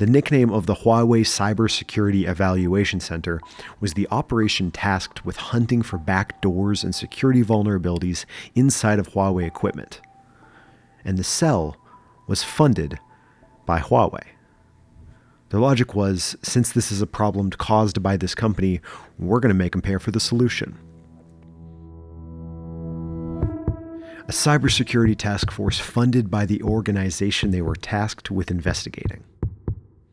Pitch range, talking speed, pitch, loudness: 90-115 Hz, 125 wpm, 100 Hz, -22 LUFS